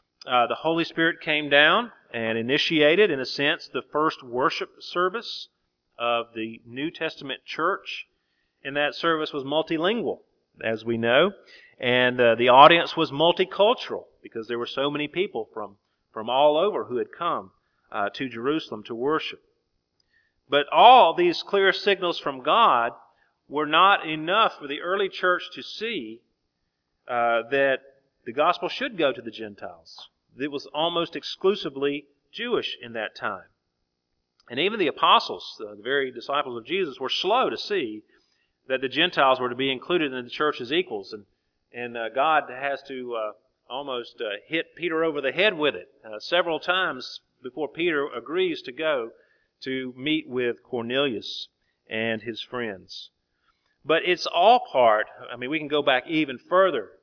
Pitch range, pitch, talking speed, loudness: 120-180 Hz, 145 Hz, 160 wpm, -23 LUFS